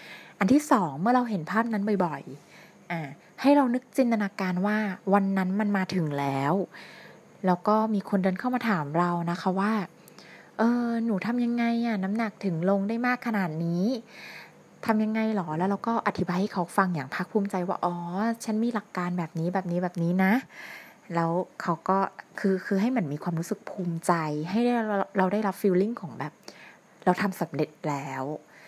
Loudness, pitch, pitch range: -27 LUFS, 195 Hz, 175-220 Hz